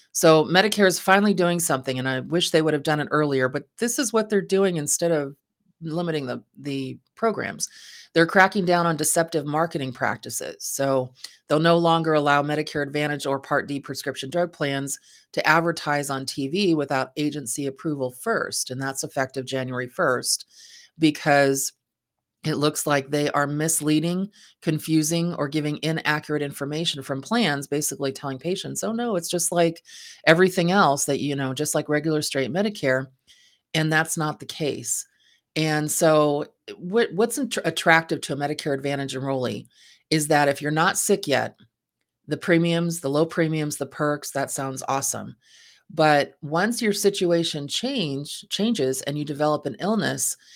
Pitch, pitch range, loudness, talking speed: 150 Hz, 140-170 Hz, -23 LUFS, 160 wpm